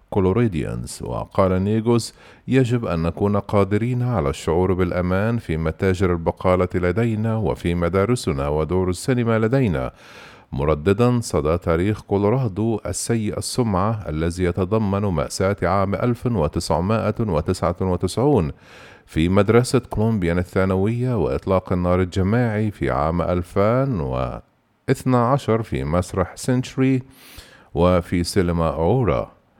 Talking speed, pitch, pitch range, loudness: 90 wpm, 95 Hz, 90-115 Hz, -21 LUFS